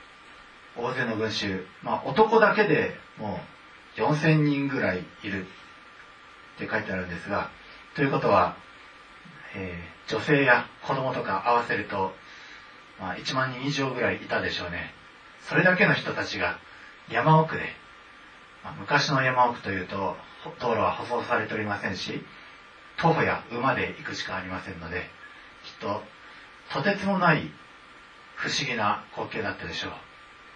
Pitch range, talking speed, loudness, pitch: 100-150 Hz, 275 characters per minute, -26 LUFS, 130 Hz